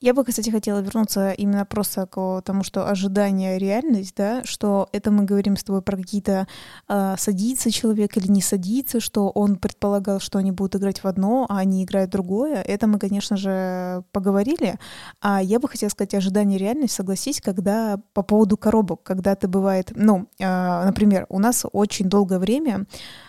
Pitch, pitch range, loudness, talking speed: 200 Hz, 195-215 Hz, -22 LUFS, 180 wpm